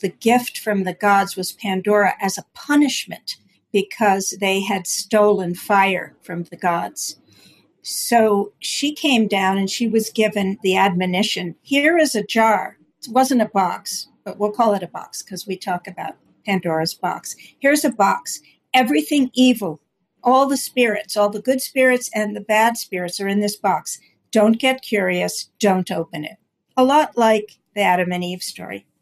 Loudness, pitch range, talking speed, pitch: -19 LUFS, 190-240 Hz, 170 wpm, 205 Hz